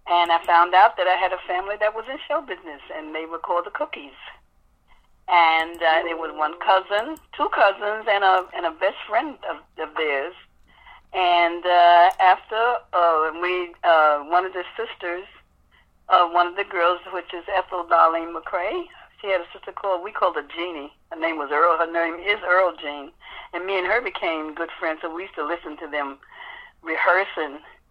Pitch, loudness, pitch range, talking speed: 175 Hz, -21 LUFS, 165-195 Hz, 195 wpm